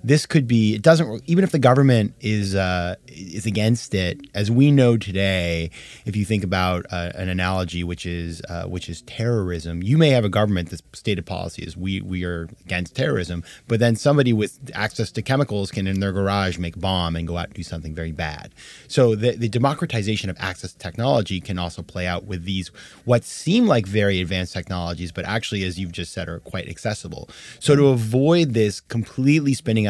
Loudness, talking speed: -21 LUFS, 205 wpm